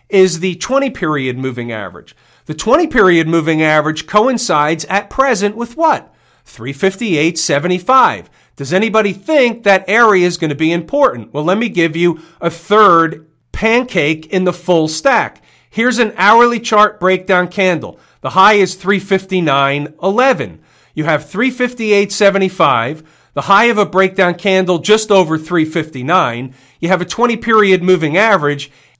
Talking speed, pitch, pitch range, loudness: 140 wpm, 185 Hz, 155-215 Hz, -13 LUFS